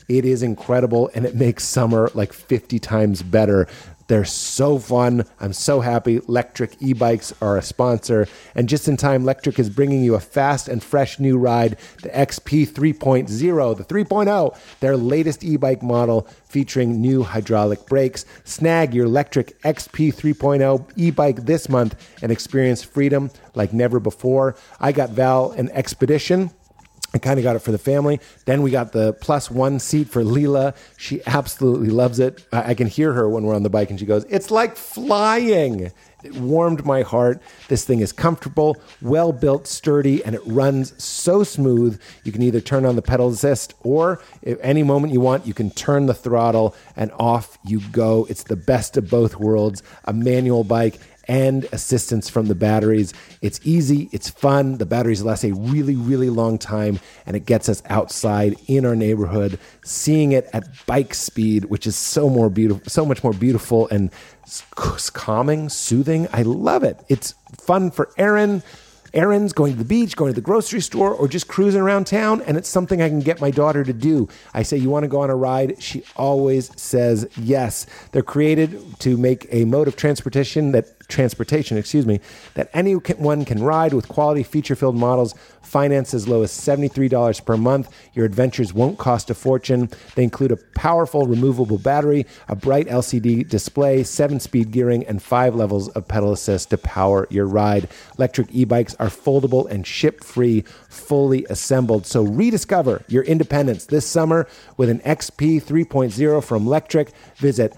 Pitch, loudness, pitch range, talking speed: 130 Hz, -19 LUFS, 115-145 Hz, 180 wpm